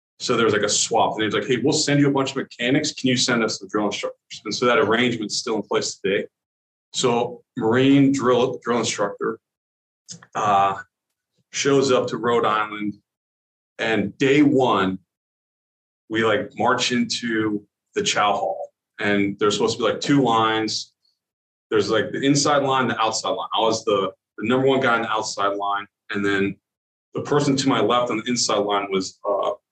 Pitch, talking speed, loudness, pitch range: 120 Hz, 190 wpm, -21 LUFS, 100-135 Hz